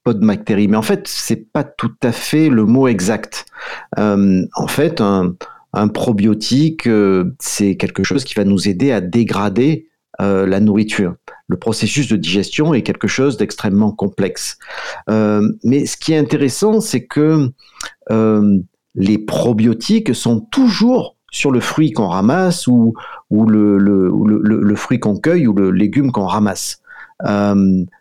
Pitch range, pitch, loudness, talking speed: 100-140 Hz, 110 Hz, -15 LUFS, 160 wpm